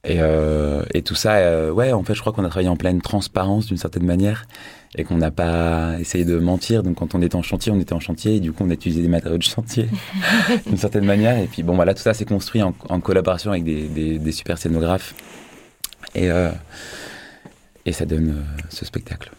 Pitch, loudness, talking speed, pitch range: 90 Hz, -20 LUFS, 235 wpm, 85-105 Hz